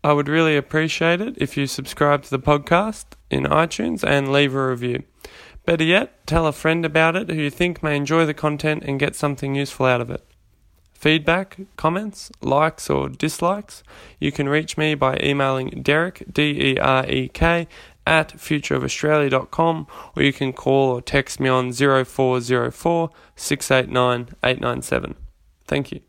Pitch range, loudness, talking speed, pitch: 130-160 Hz, -20 LUFS, 150 wpm, 145 Hz